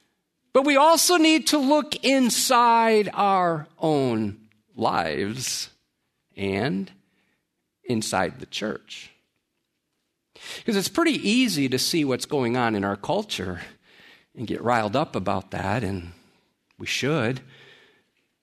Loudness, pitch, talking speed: -23 LUFS, 150 Hz, 115 wpm